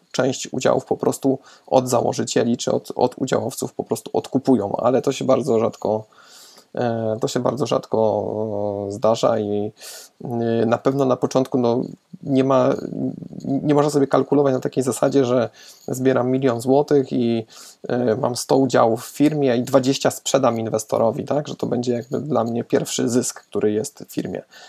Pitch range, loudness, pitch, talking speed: 110-135 Hz, -21 LUFS, 125 Hz, 160 wpm